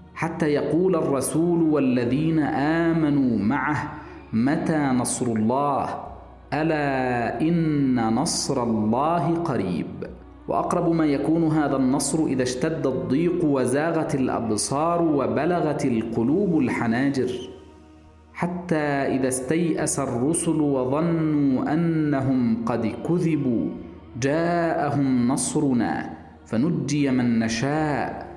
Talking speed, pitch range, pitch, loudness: 85 wpm, 125-160 Hz, 145 Hz, -23 LUFS